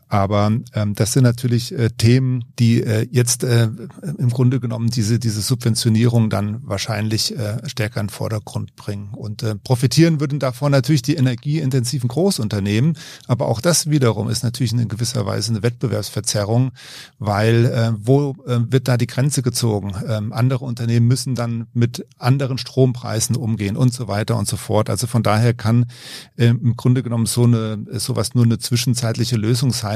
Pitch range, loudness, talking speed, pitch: 110-130 Hz, -19 LUFS, 170 wpm, 120 Hz